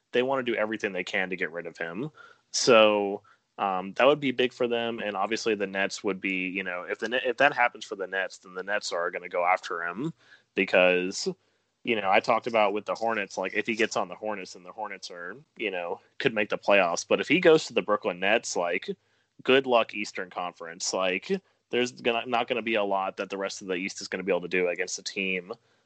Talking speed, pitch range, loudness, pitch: 255 wpm, 95-120 Hz, -27 LUFS, 105 Hz